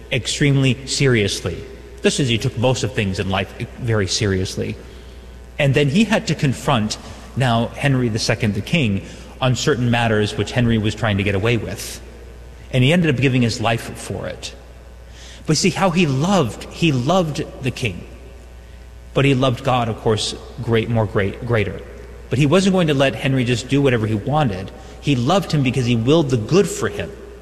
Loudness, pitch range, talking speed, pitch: -19 LUFS, 100-140 Hz, 185 wpm, 120 Hz